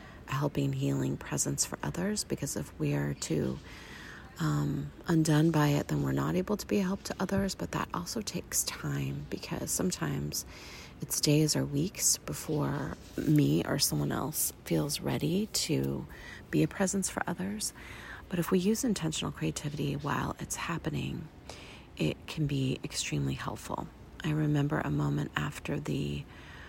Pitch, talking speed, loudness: 145 Hz, 155 wpm, -32 LUFS